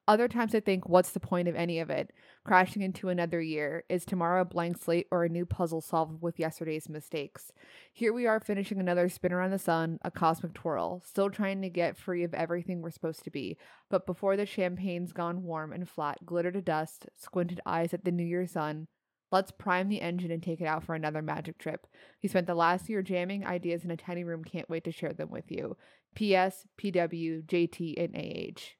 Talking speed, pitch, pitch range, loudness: 215 wpm, 175 Hz, 165-185 Hz, -32 LUFS